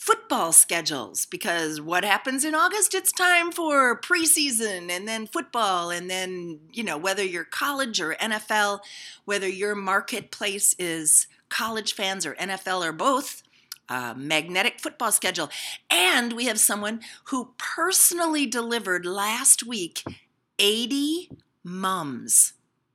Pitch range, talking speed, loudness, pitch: 185-275 Hz, 125 wpm, -23 LUFS, 210 Hz